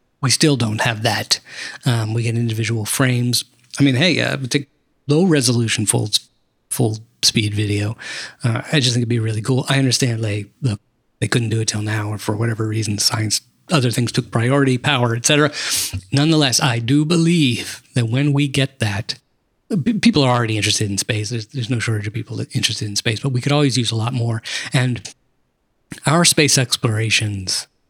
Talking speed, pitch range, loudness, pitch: 190 wpm, 110-135 Hz, -18 LUFS, 120 Hz